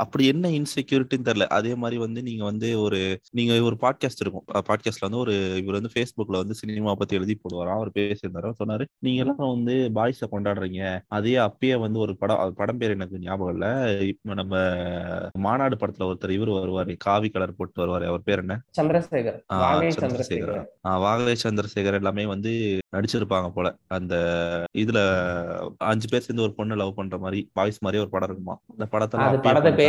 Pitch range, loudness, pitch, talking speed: 95-115 Hz, -25 LUFS, 105 Hz, 165 wpm